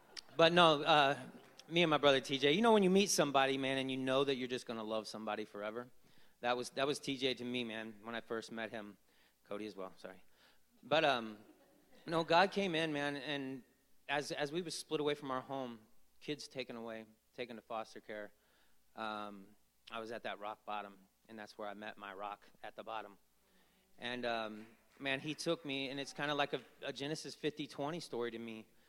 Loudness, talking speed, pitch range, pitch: -37 LUFS, 215 wpm, 110-145 Hz, 125 Hz